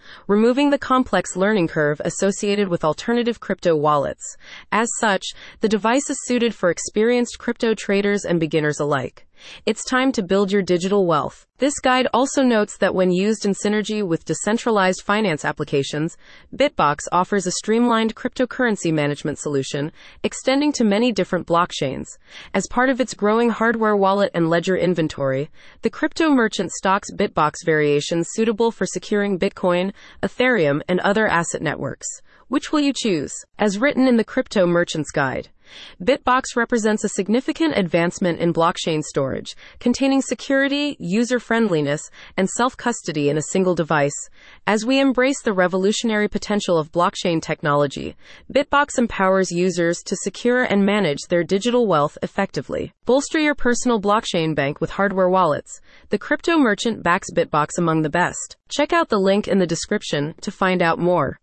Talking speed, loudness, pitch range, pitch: 150 wpm, -20 LUFS, 170-235 Hz, 200 Hz